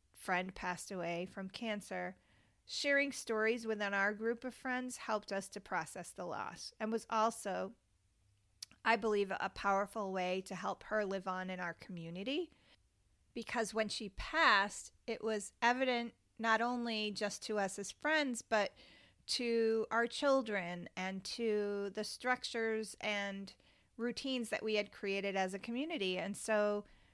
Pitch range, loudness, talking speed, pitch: 195-230 Hz, -38 LUFS, 150 wpm, 210 Hz